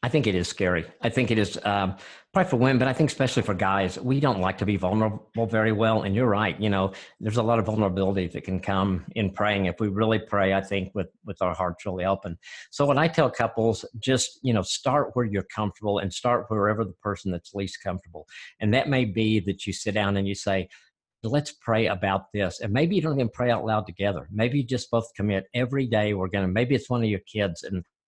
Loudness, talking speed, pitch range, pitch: -25 LUFS, 245 wpm, 95-120 Hz, 105 Hz